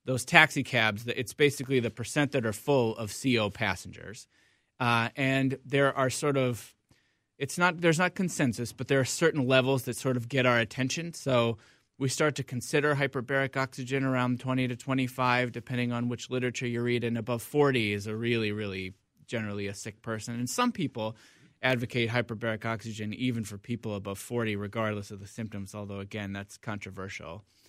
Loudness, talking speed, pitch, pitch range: -29 LUFS, 180 wpm, 120 Hz, 110-135 Hz